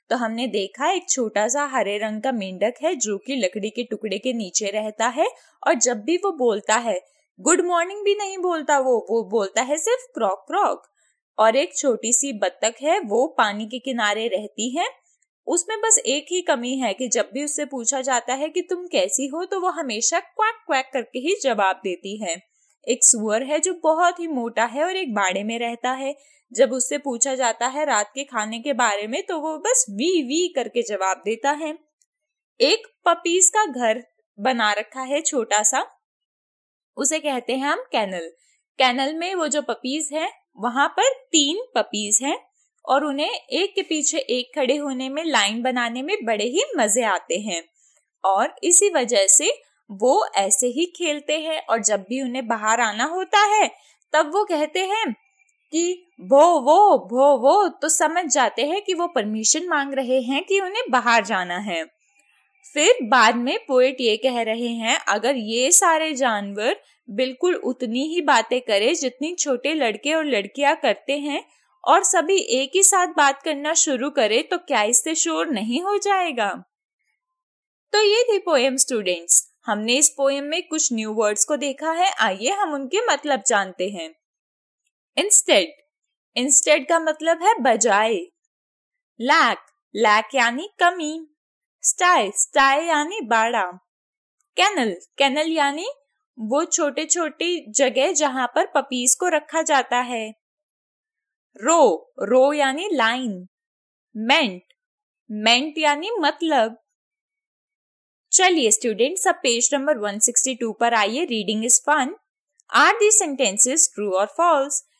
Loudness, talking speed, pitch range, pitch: -20 LUFS, 160 wpm, 235-340 Hz, 280 Hz